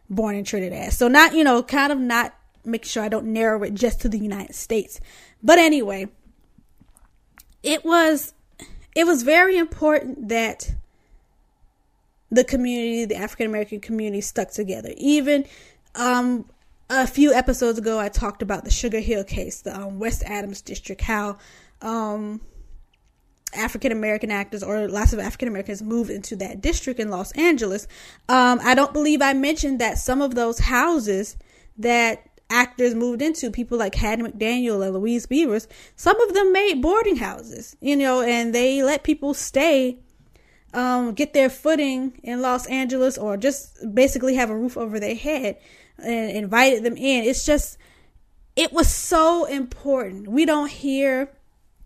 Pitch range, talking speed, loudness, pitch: 215-275 Hz, 160 wpm, -21 LUFS, 245 Hz